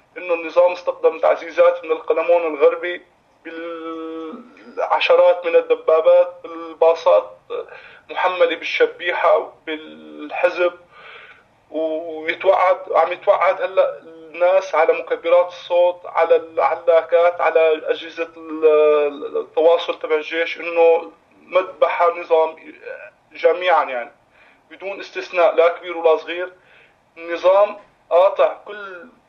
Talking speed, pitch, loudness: 90 wpm, 175 Hz, -18 LUFS